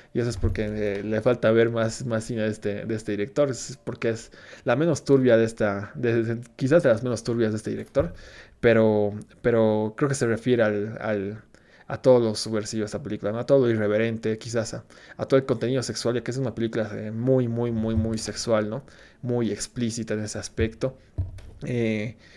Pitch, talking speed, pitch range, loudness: 115 Hz, 210 wpm, 105-120 Hz, -25 LUFS